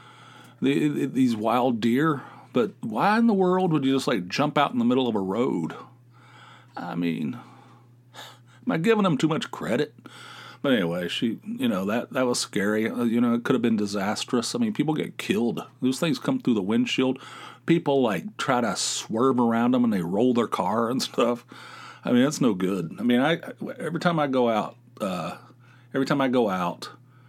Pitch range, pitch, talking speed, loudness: 120-185 Hz, 130 Hz, 195 wpm, -25 LUFS